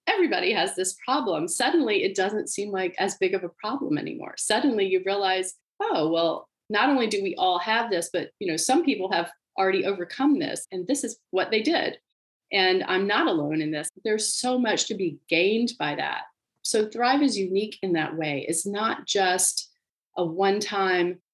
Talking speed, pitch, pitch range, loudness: 195 wpm, 200 Hz, 185-260 Hz, -25 LUFS